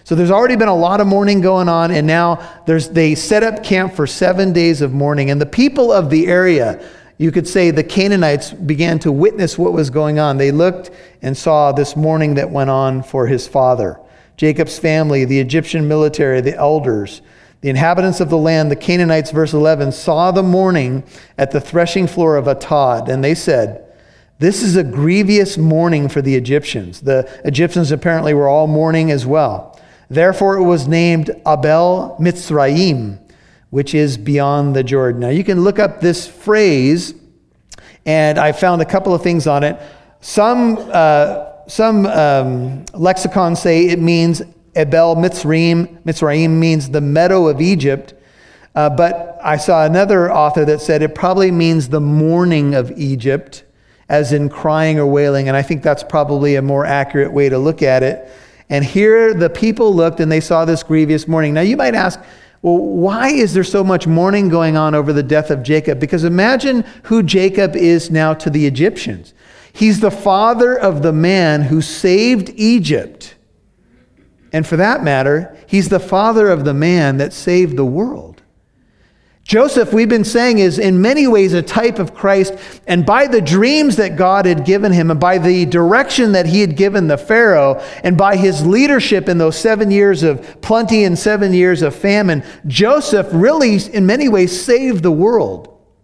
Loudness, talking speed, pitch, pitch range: -13 LUFS, 180 wpm, 165 Hz, 150-190 Hz